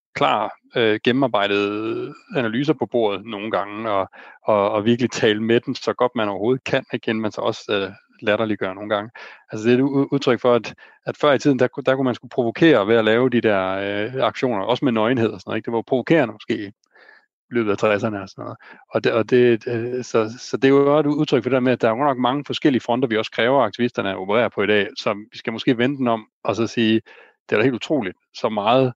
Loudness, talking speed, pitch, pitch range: -20 LUFS, 245 wpm, 120 Hz, 110-130 Hz